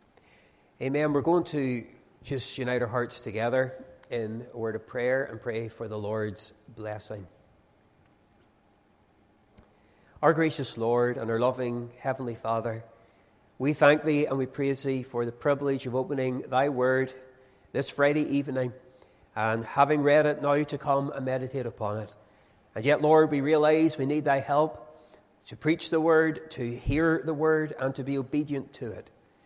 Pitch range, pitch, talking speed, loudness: 115-145 Hz, 130 Hz, 160 wpm, -27 LUFS